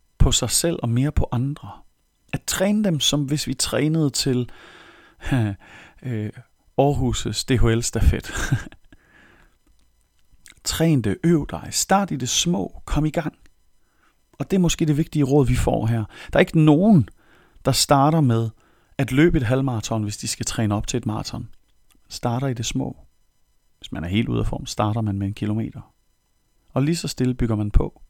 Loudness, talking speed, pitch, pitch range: -22 LUFS, 170 wpm, 125 Hz, 110-150 Hz